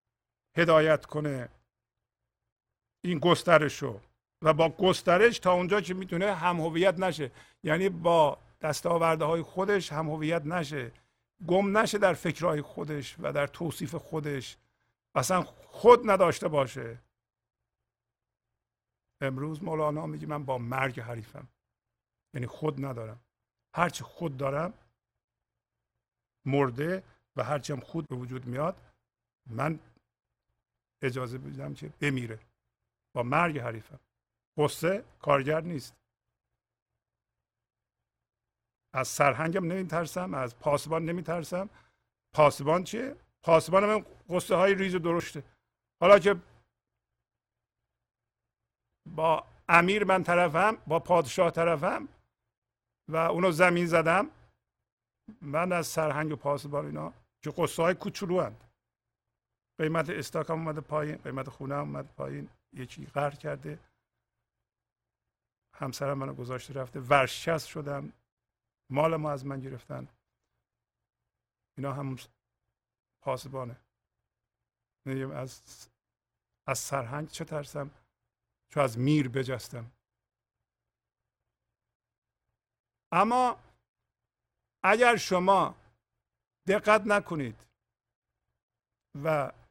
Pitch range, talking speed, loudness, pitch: 130-170 Hz, 100 wpm, -29 LUFS, 150 Hz